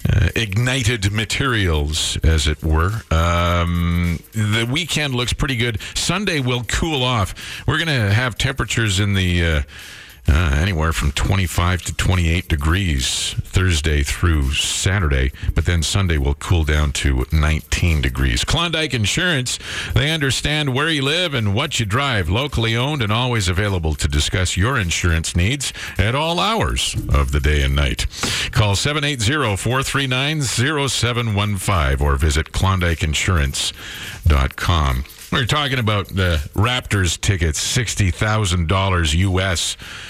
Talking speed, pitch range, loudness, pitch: 130 wpm, 80-120 Hz, -19 LUFS, 95 Hz